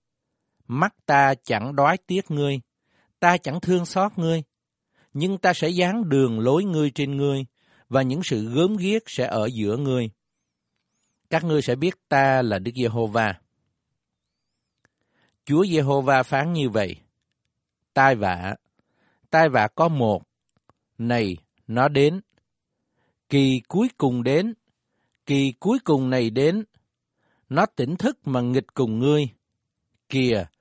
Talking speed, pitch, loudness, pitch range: 135 wpm, 135 Hz, -22 LUFS, 120-165 Hz